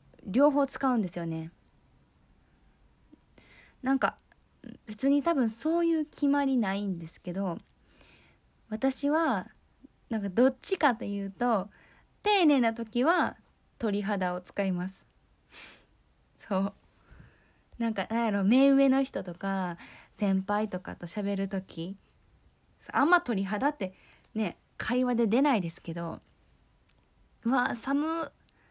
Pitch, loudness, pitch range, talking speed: 220 Hz, -29 LUFS, 190-270 Hz, 205 characters per minute